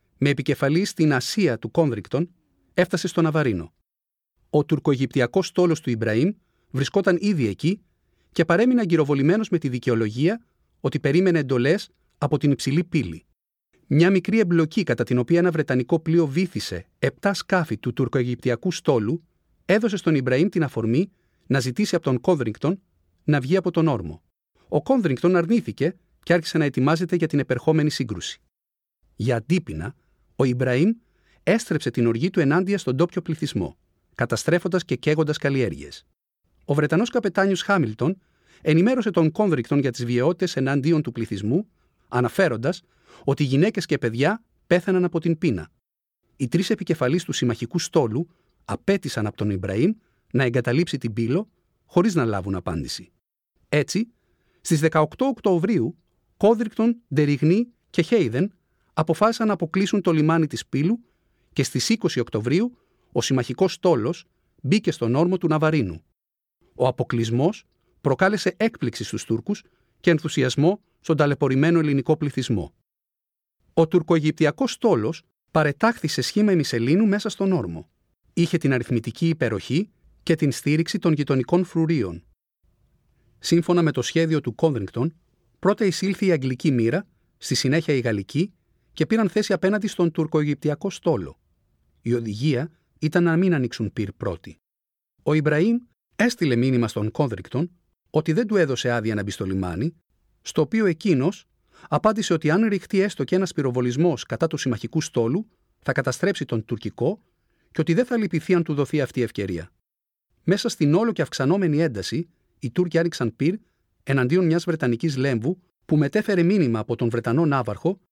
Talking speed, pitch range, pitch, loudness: 145 wpm, 125-180 Hz, 160 Hz, -23 LUFS